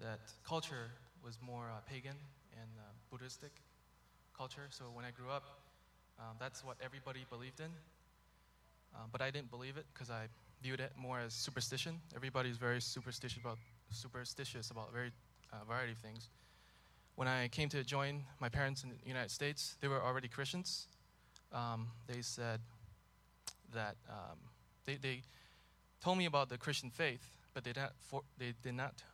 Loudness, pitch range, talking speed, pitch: -44 LUFS, 115-135 Hz, 165 wpm, 125 Hz